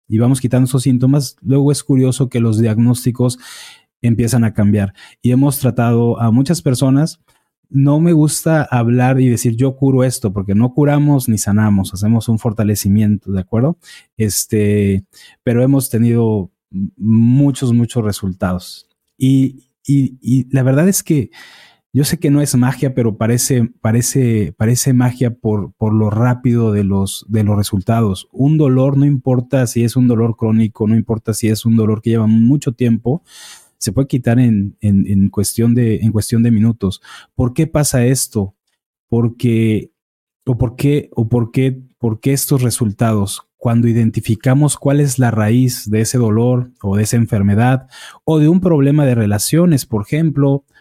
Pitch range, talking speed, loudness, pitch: 110-135 Hz, 165 wpm, -15 LUFS, 120 Hz